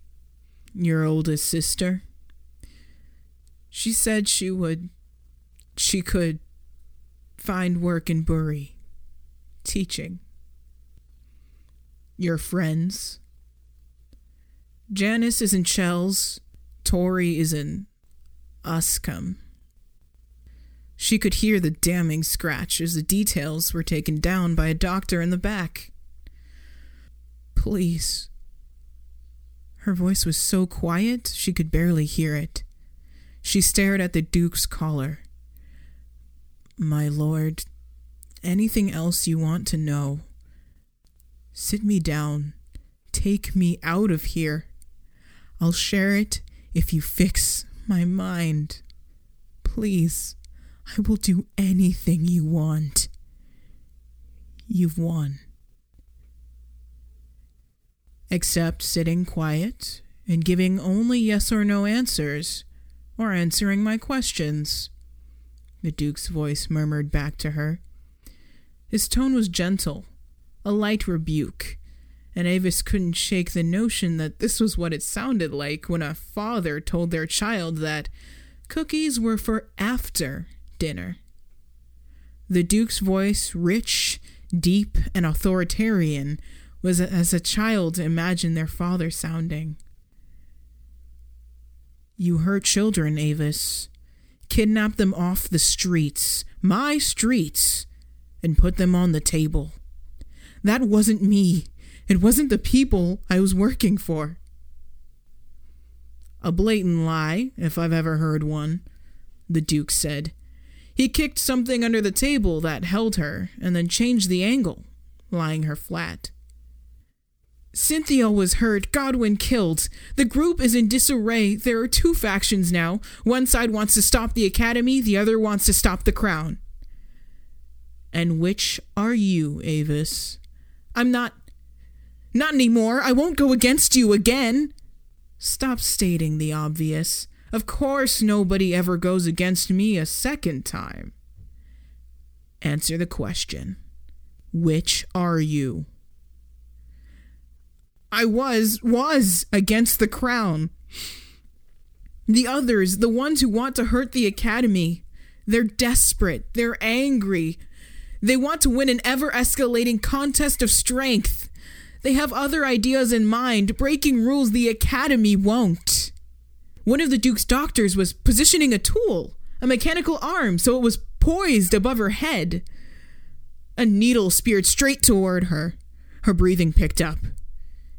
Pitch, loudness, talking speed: 165 Hz, -22 LUFS, 120 wpm